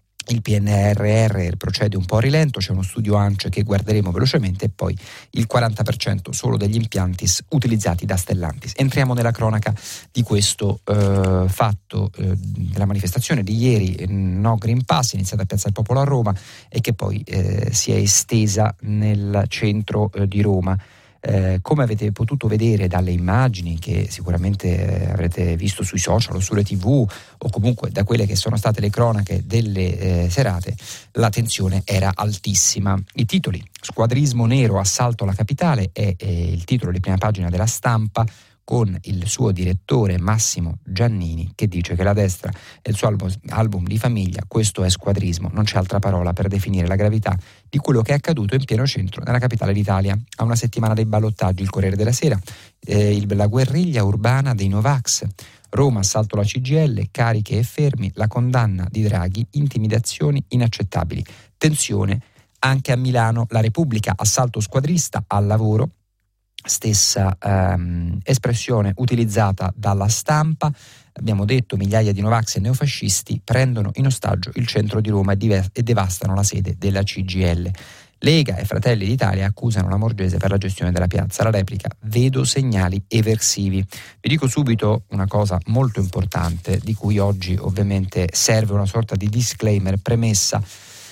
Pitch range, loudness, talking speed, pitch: 95-115 Hz, -19 LUFS, 165 wpm, 105 Hz